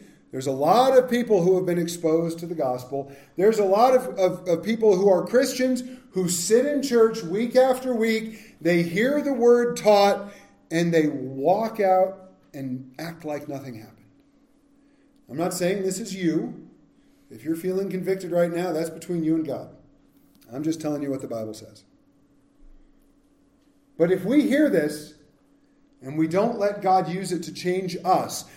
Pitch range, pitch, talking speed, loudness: 160-245 Hz, 185 Hz, 175 wpm, -23 LUFS